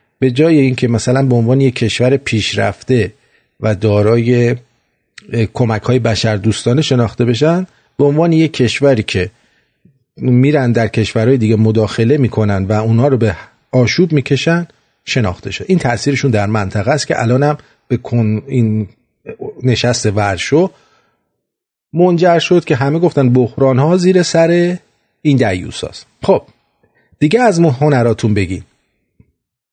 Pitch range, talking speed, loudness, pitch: 110-145 Hz, 135 wpm, -13 LUFS, 125 Hz